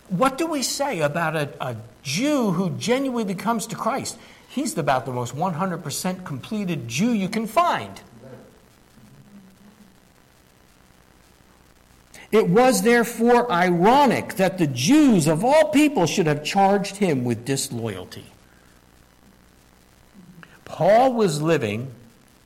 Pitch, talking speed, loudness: 180 Hz, 110 wpm, -21 LUFS